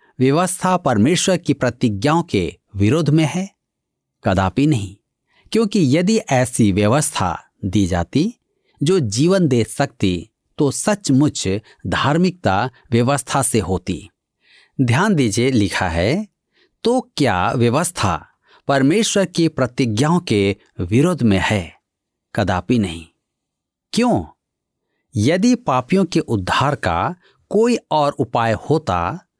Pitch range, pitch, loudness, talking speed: 105-170 Hz, 135 Hz, -18 LUFS, 105 wpm